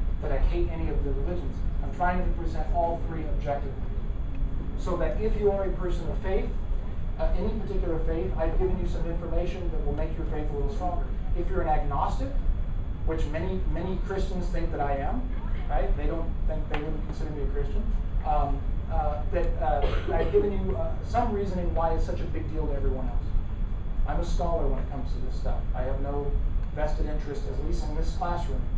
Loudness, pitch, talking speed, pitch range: -31 LUFS, 85 Hz, 210 wpm, 80-95 Hz